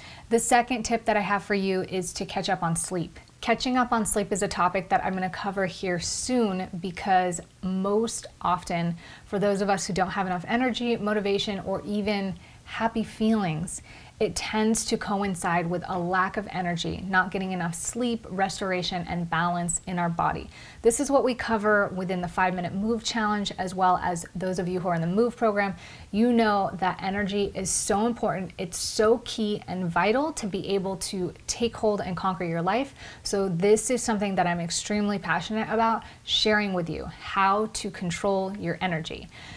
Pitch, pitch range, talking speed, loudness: 195 Hz, 185-215 Hz, 190 wpm, -26 LUFS